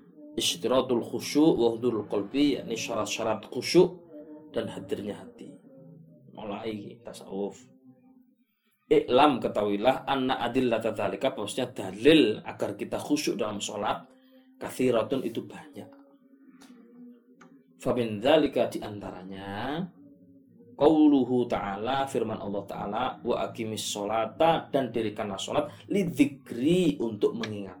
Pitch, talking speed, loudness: 135 Hz, 95 wpm, -27 LUFS